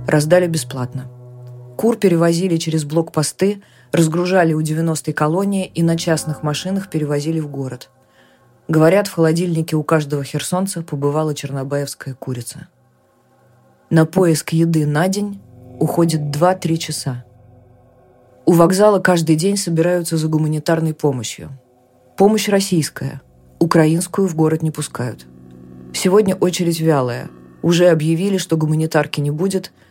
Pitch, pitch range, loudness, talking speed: 155 Hz, 135-175 Hz, -17 LUFS, 115 wpm